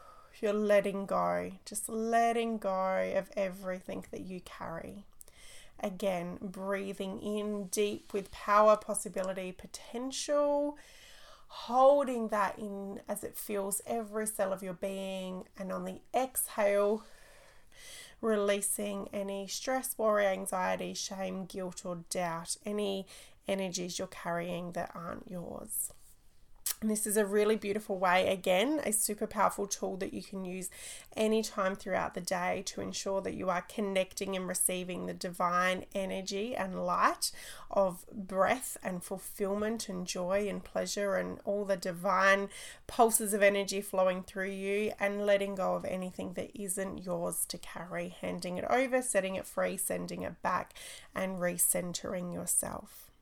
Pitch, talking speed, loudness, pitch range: 195 Hz, 140 wpm, -33 LUFS, 185-210 Hz